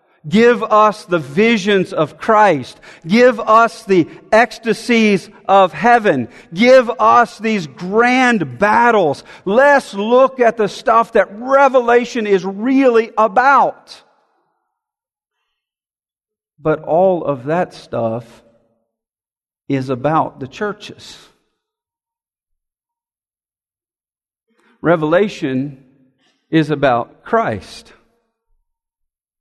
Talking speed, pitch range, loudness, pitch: 80 wpm, 160-240 Hz, -14 LUFS, 215 Hz